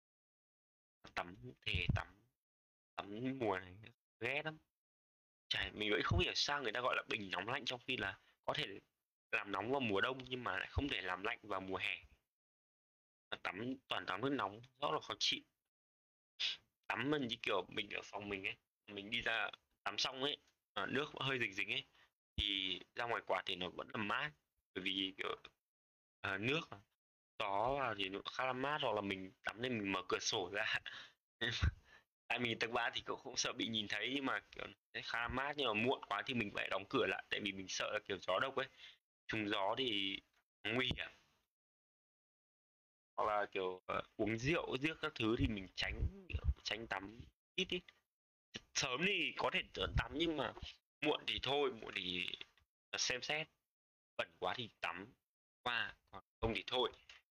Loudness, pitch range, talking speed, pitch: -40 LUFS, 90-125 Hz, 190 wpm, 100 Hz